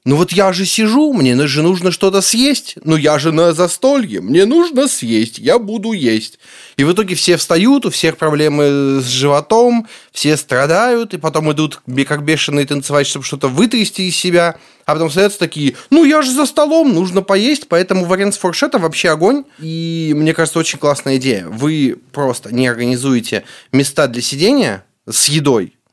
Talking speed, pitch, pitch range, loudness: 175 wpm, 165 Hz, 145-205 Hz, -13 LUFS